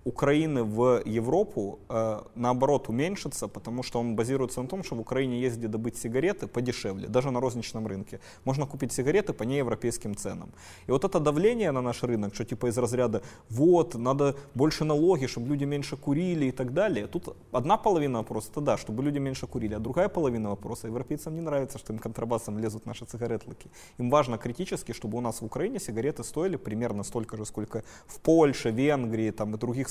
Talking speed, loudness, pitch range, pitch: 190 wpm, -29 LUFS, 115-140 Hz, 125 Hz